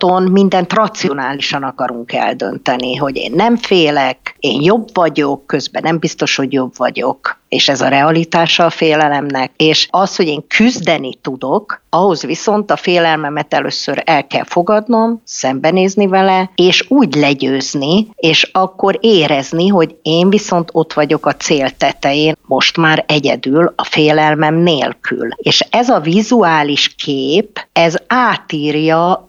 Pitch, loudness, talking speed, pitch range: 160 Hz, -12 LUFS, 135 wpm, 145-190 Hz